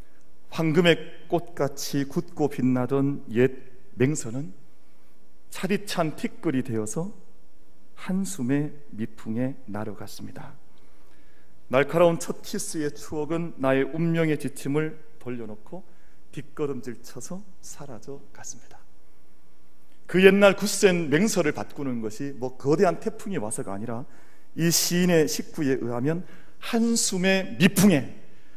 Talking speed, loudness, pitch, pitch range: 240 characters per minute, -25 LUFS, 140 Hz, 110-170 Hz